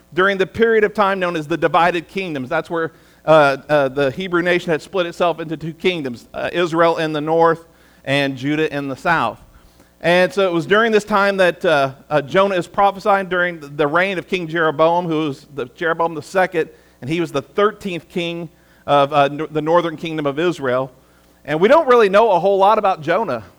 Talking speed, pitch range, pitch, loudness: 205 wpm, 150-180 Hz, 165 Hz, -17 LUFS